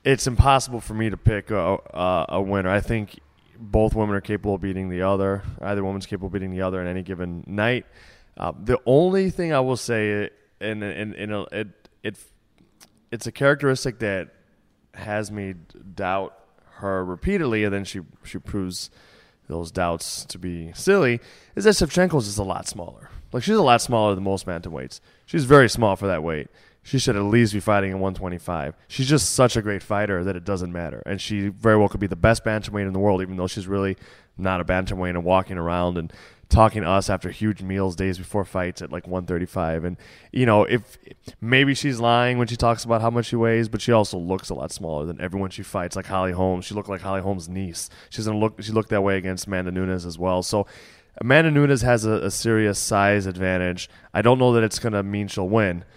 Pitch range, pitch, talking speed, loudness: 95-110 Hz, 100 Hz, 220 wpm, -23 LUFS